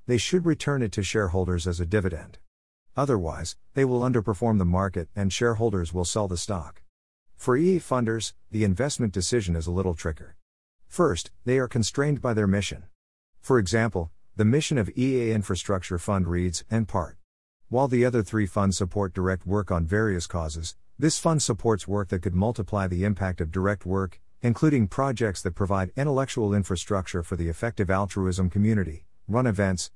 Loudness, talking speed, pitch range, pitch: -26 LUFS, 170 wpm, 90-115 Hz, 100 Hz